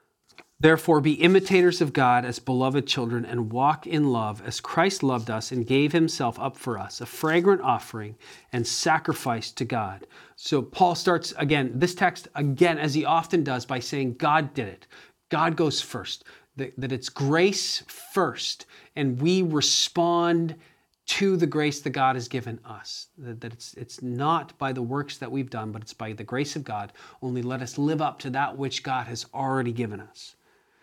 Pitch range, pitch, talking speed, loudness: 125-160 Hz, 135 Hz, 180 wpm, -25 LUFS